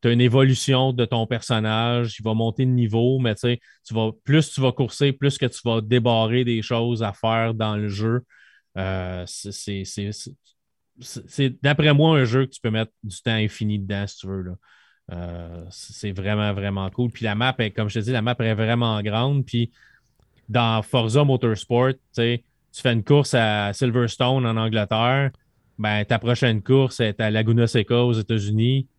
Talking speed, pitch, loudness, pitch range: 195 wpm, 115 Hz, -22 LUFS, 110-125 Hz